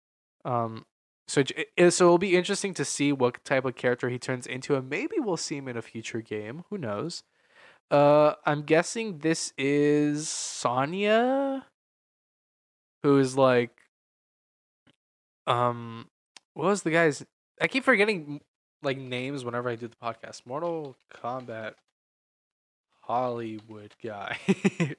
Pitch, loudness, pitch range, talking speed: 140 Hz, -27 LUFS, 120-165 Hz, 130 wpm